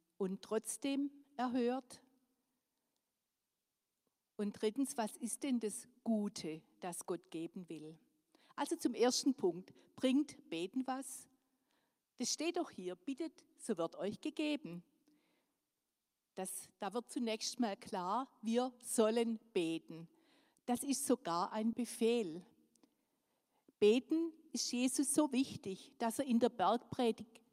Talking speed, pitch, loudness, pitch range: 120 wpm, 245 Hz, -39 LUFS, 215-280 Hz